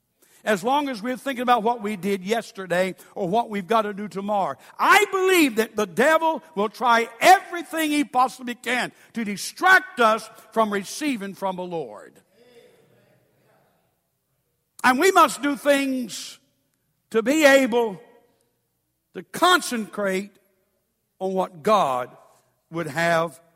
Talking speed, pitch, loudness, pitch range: 130 wpm, 225 Hz, -22 LUFS, 195-275 Hz